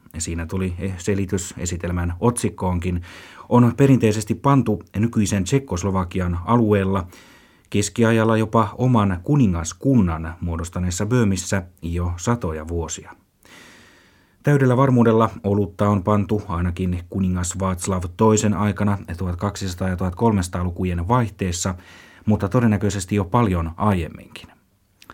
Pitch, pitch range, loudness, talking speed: 100 Hz, 90-110 Hz, -21 LUFS, 95 wpm